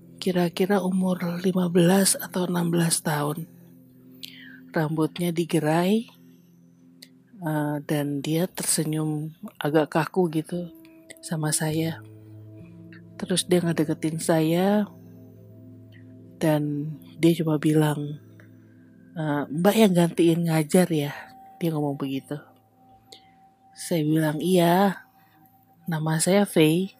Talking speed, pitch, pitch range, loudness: 85 wpm, 155 Hz, 140-175 Hz, -24 LUFS